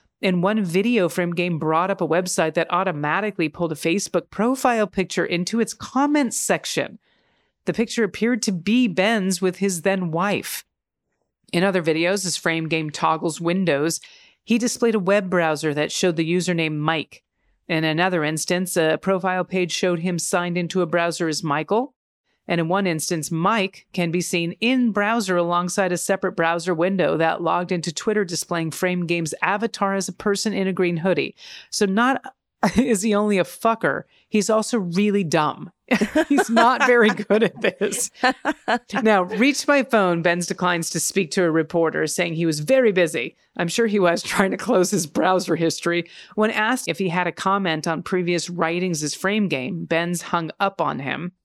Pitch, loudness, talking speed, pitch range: 185 Hz, -21 LUFS, 180 wpm, 170-210 Hz